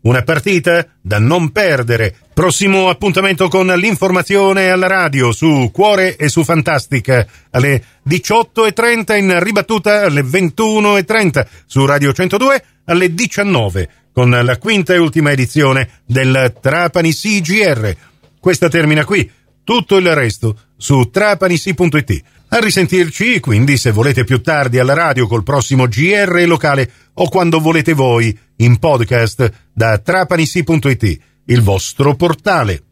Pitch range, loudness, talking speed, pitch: 125-185 Hz, -12 LUFS, 125 wpm, 160 Hz